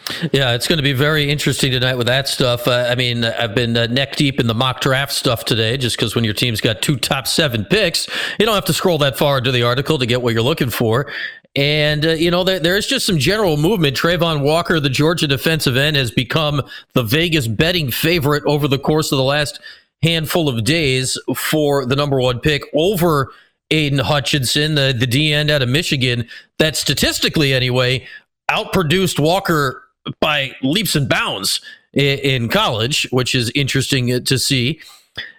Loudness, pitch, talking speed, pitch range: -16 LUFS, 145 Hz, 190 wpm, 130-160 Hz